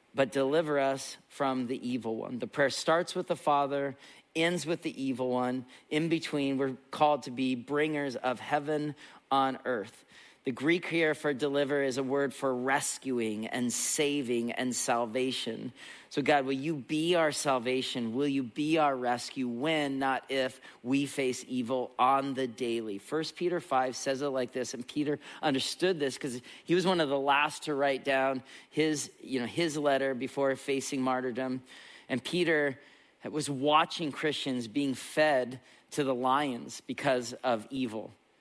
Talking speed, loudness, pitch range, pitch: 165 wpm, -31 LUFS, 130-150 Hz, 135 Hz